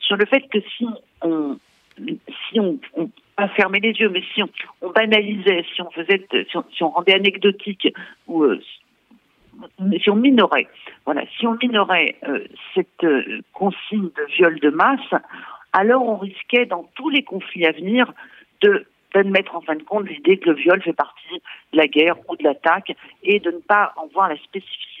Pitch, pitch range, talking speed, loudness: 195 Hz, 170-220 Hz, 190 wpm, -19 LUFS